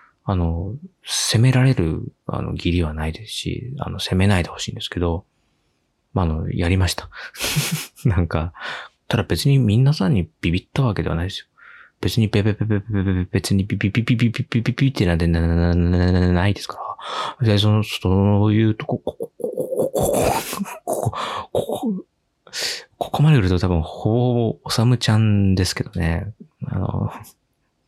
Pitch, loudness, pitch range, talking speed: 105 Hz, -21 LUFS, 90-125 Hz, 290 characters per minute